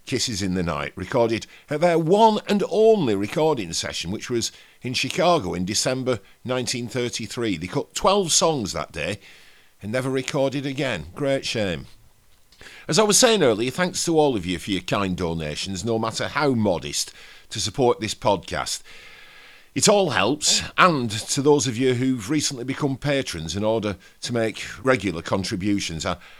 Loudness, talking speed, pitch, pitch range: -22 LUFS, 165 wpm, 125 Hz, 100-145 Hz